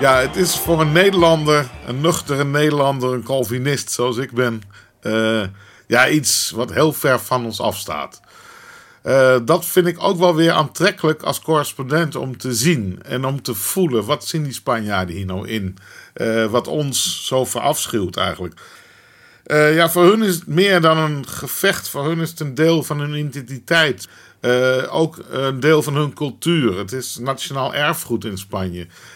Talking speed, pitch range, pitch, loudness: 175 wpm, 125-160 Hz, 140 Hz, -18 LUFS